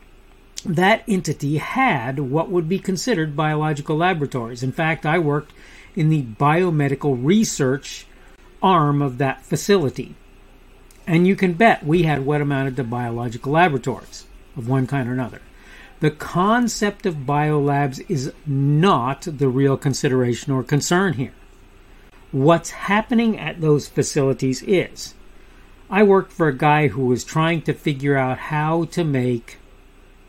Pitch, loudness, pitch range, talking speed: 150 Hz, -20 LUFS, 135-175 Hz, 135 wpm